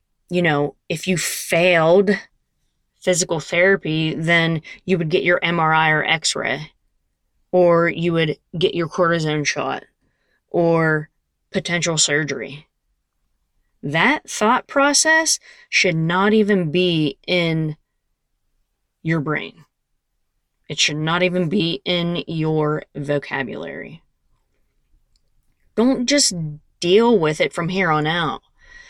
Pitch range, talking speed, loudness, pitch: 155-185 Hz, 110 wpm, -18 LUFS, 170 Hz